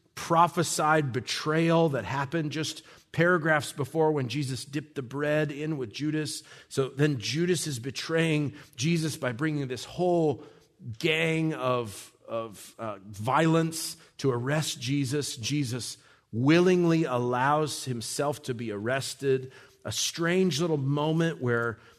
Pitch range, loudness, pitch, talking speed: 130-160 Hz, -28 LUFS, 150 Hz, 125 wpm